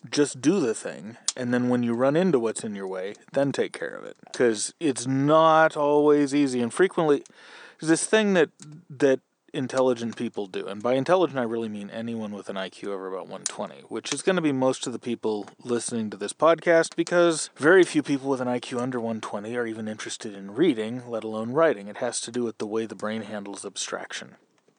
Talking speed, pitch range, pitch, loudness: 215 wpm, 110-155 Hz, 125 Hz, -25 LUFS